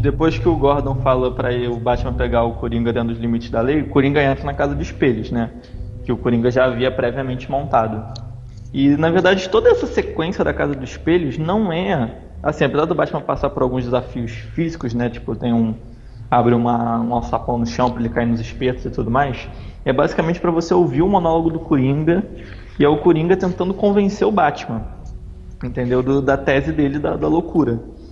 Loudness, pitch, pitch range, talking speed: -18 LUFS, 125 Hz, 115-150 Hz, 205 wpm